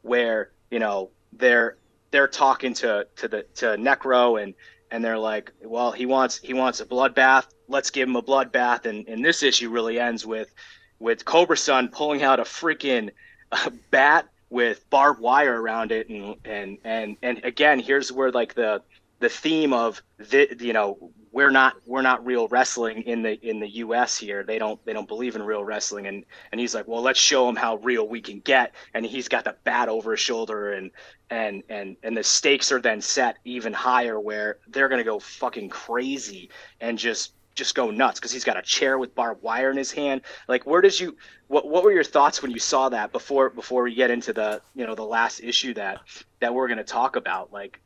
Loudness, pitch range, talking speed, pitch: -23 LUFS, 110-135 Hz, 210 wpm, 120 Hz